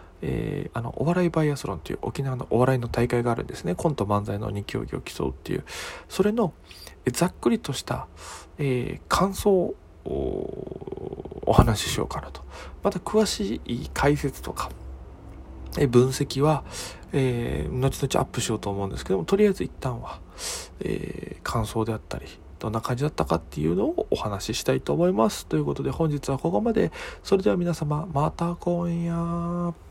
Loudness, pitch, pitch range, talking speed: -26 LUFS, 130 Hz, 105-170 Hz, 305 characters per minute